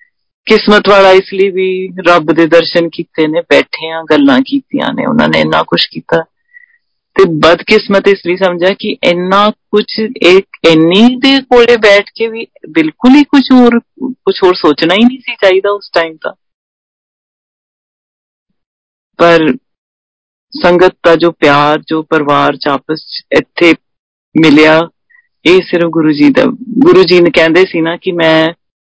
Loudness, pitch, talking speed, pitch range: -8 LUFS, 190 Hz, 150 wpm, 165-240 Hz